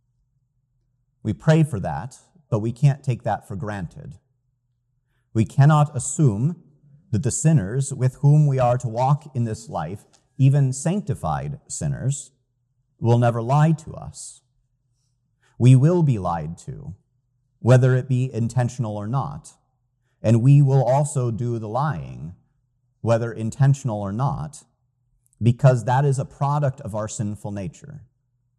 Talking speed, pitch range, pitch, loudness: 135 wpm, 120-140 Hz, 130 Hz, -21 LUFS